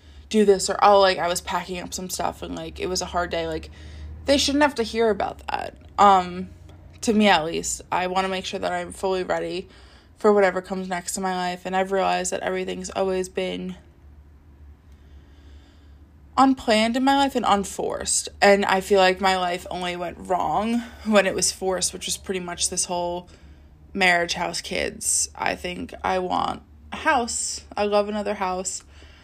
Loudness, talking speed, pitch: -23 LUFS, 190 wpm, 180 Hz